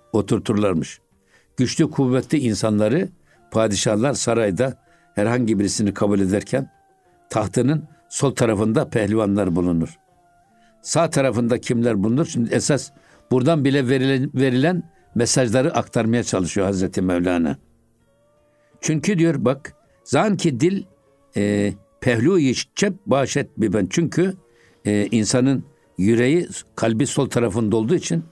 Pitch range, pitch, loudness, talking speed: 110-150 Hz, 120 Hz, -20 LUFS, 100 wpm